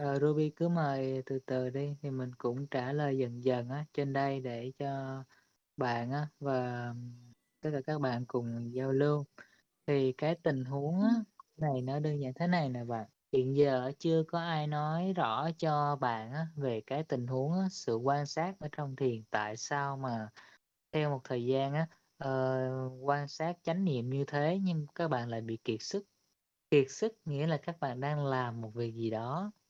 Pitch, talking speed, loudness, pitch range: 140 Hz, 195 wpm, -34 LUFS, 130-155 Hz